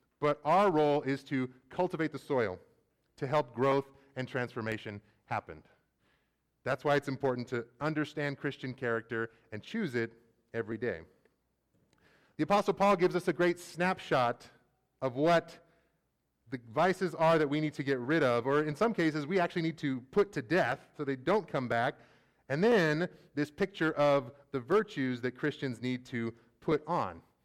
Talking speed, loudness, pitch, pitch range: 165 wpm, -32 LUFS, 140 Hz, 125-165 Hz